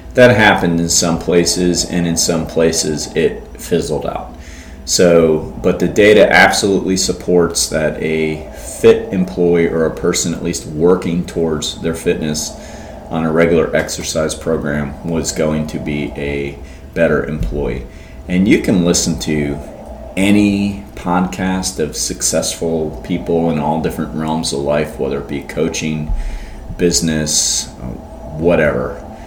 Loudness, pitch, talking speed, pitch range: -15 LUFS, 80 Hz, 135 wpm, 75-85 Hz